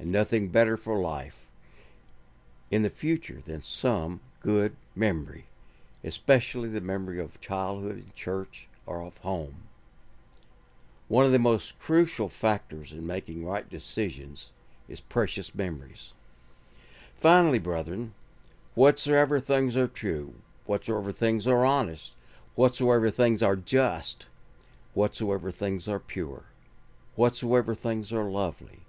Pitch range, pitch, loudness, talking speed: 85-120 Hz, 105 Hz, -28 LUFS, 120 wpm